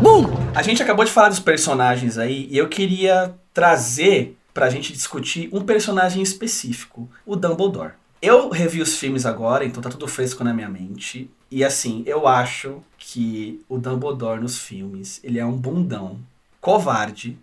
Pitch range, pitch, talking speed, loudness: 120-180 Hz, 135 Hz, 160 wpm, -19 LUFS